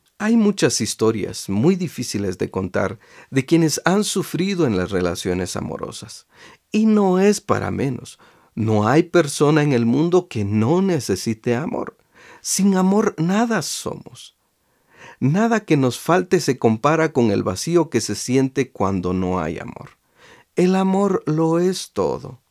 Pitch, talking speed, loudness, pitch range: 150 Hz, 145 wpm, -19 LUFS, 110-185 Hz